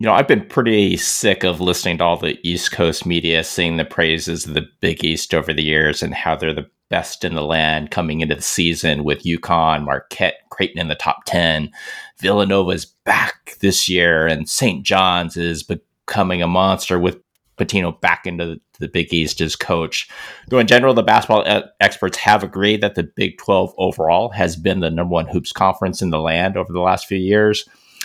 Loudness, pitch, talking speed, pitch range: -17 LUFS, 85 Hz, 200 wpm, 80-95 Hz